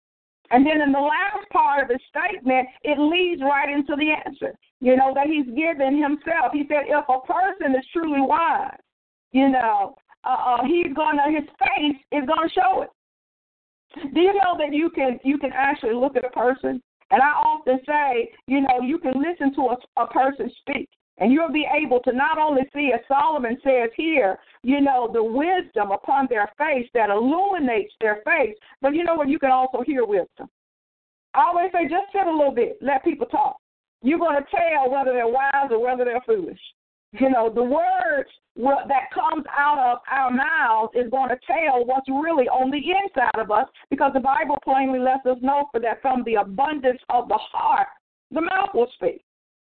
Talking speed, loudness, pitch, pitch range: 195 wpm, -21 LUFS, 280 Hz, 255-335 Hz